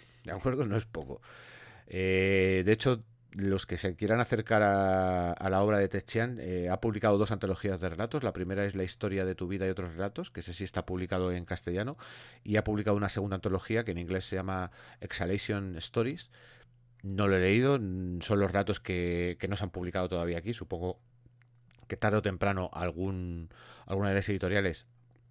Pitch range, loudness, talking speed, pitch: 90-110 Hz, -31 LUFS, 195 wpm, 100 Hz